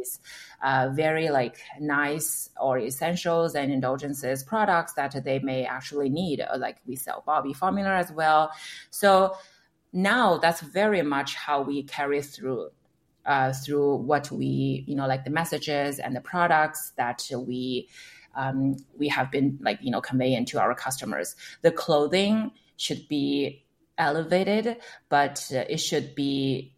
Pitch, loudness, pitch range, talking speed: 145 Hz, -26 LUFS, 135-165 Hz, 145 wpm